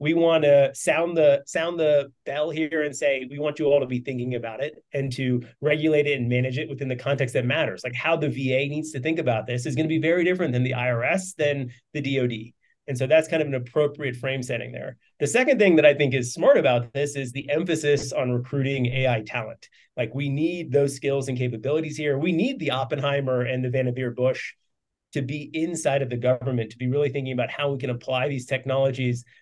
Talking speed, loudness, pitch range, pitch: 230 wpm, -24 LUFS, 125-150 Hz, 140 Hz